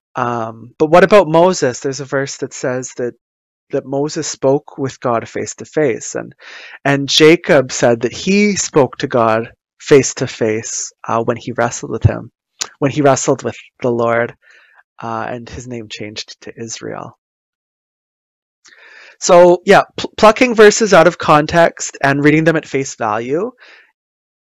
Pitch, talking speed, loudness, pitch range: 135 Hz, 155 wpm, -14 LUFS, 120-155 Hz